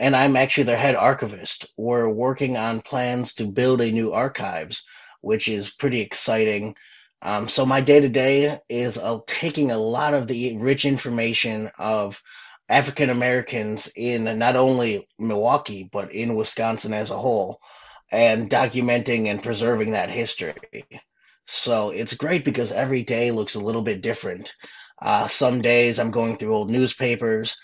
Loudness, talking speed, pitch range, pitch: -21 LUFS, 155 wpm, 110-130 Hz, 120 Hz